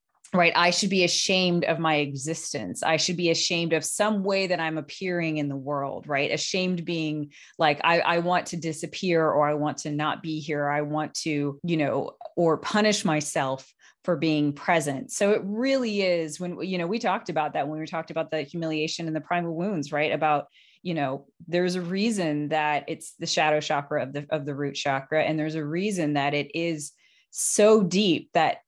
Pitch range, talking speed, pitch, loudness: 150-175 Hz, 205 wpm, 160 Hz, -25 LUFS